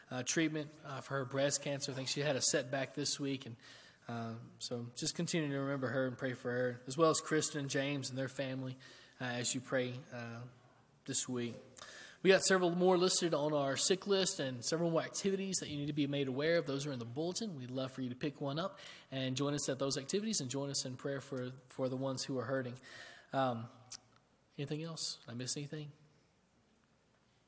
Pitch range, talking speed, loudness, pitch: 130-155 Hz, 220 wpm, -36 LUFS, 140 Hz